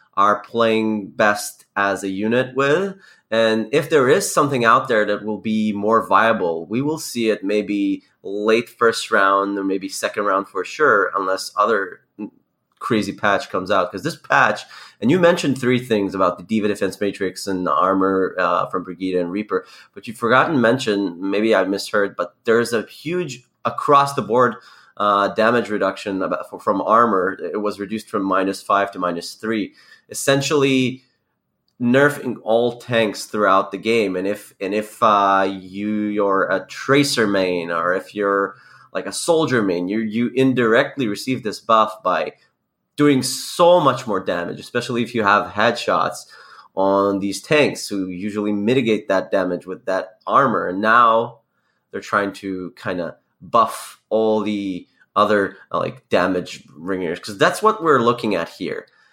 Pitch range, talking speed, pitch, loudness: 100-120 Hz, 165 wpm, 105 Hz, -19 LUFS